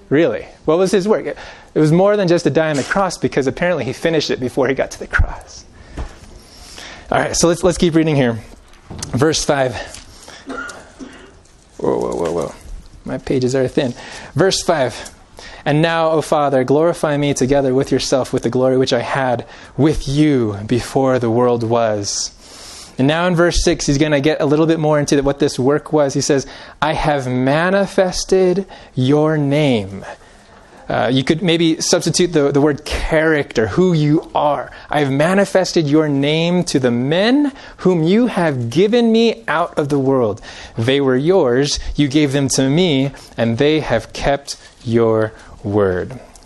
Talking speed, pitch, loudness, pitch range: 175 wpm, 145 Hz, -16 LUFS, 130-165 Hz